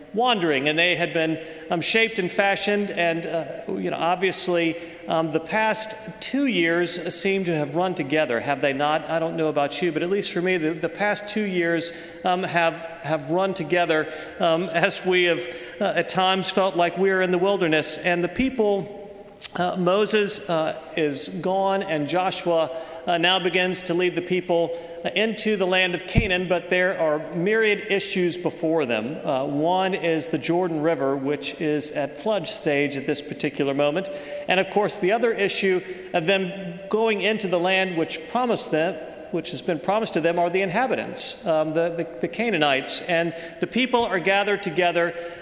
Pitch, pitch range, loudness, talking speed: 175 Hz, 165-195 Hz, -23 LUFS, 185 wpm